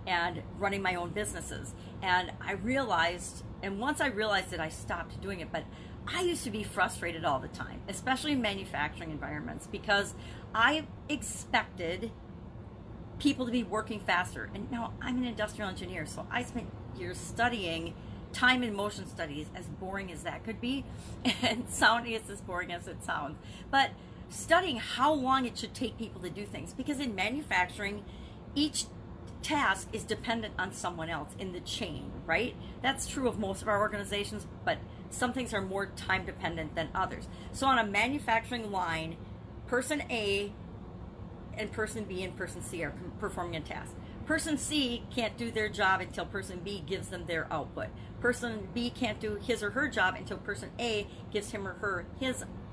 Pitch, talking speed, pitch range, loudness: 225 Hz, 175 wpm, 200-255 Hz, -33 LUFS